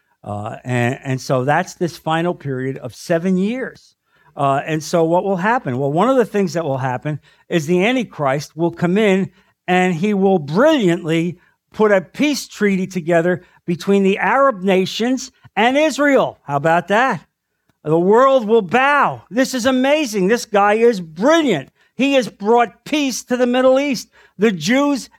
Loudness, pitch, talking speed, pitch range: -17 LUFS, 190 Hz, 165 wpm, 165-240 Hz